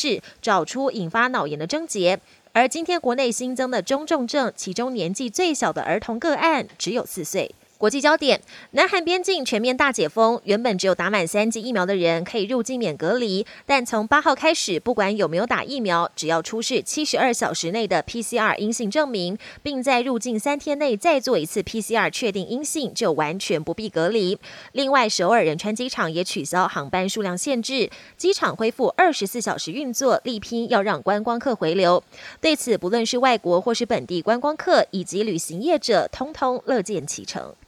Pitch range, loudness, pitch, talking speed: 195-270 Hz, -22 LUFS, 230 Hz, 300 characters per minute